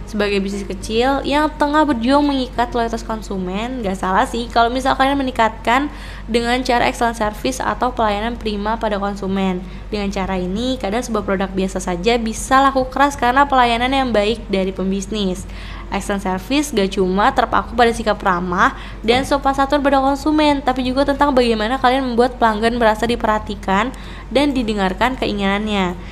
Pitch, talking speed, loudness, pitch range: 230 Hz, 155 wpm, -18 LUFS, 200-260 Hz